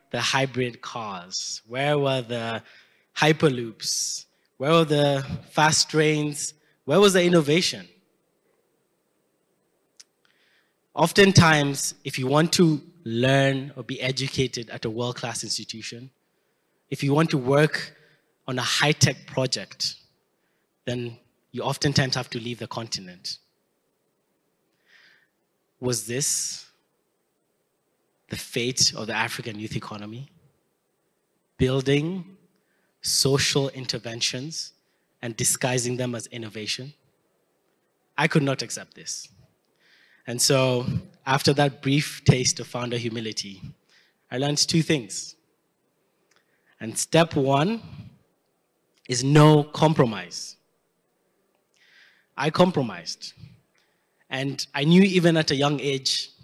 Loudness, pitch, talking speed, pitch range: -23 LUFS, 140 Hz, 105 wpm, 125-155 Hz